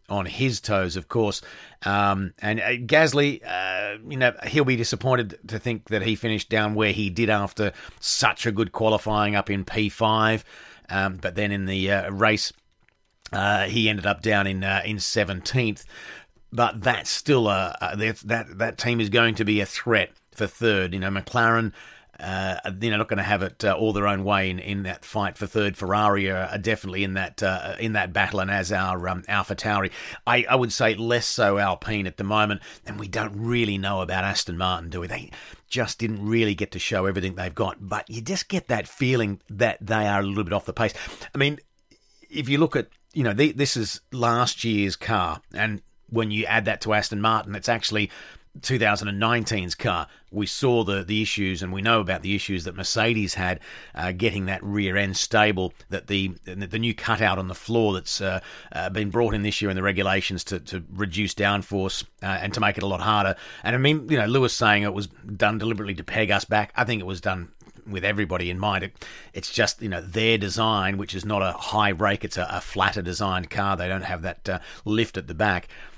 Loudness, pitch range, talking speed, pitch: -24 LUFS, 95-115 Hz, 220 wpm, 105 Hz